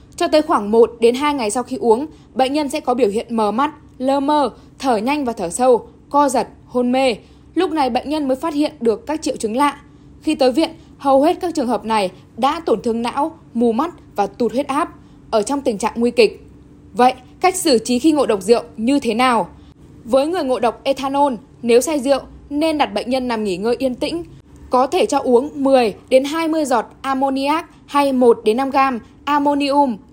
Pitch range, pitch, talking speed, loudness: 235-290 Hz, 270 Hz, 215 wpm, -18 LUFS